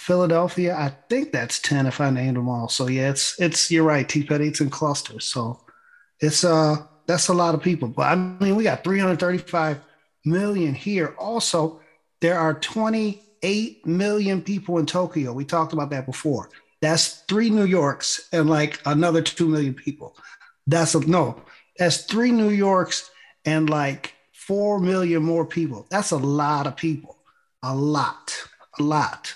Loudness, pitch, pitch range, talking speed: -22 LUFS, 160 Hz, 150-180 Hz, 170 wpm